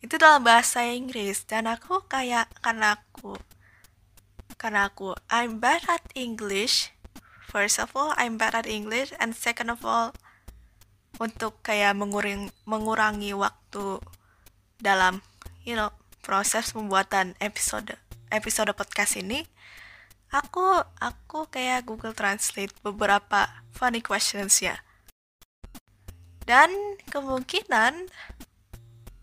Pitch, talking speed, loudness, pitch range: 210 Hz, 105 wpm, -25 LUFS, 190-240 Hz